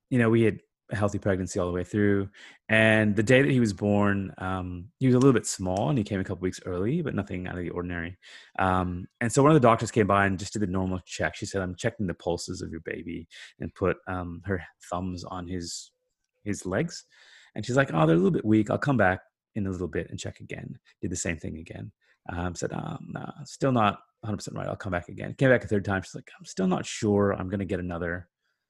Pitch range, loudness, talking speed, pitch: 90-110 Hz, -27 LUFS, 255 wpm, 100 Hz